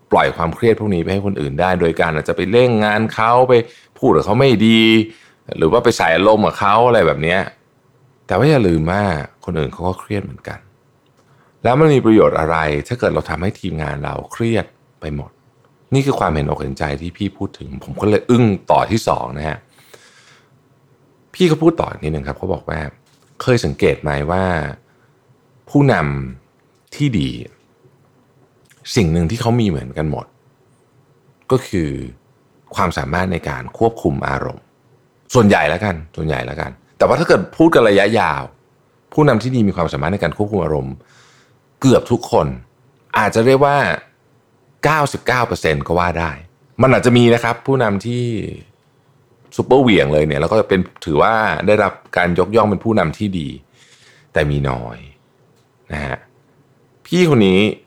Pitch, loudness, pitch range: 105 Hz, -16 LUFS, 80-130 Hz